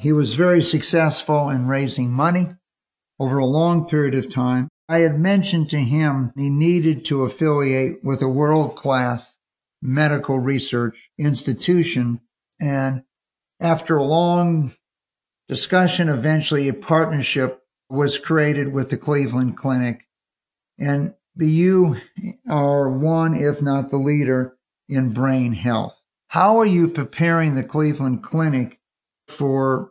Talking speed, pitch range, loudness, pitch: 125 wpm, 130-160 Hz, -20 LUFS, 145 Hz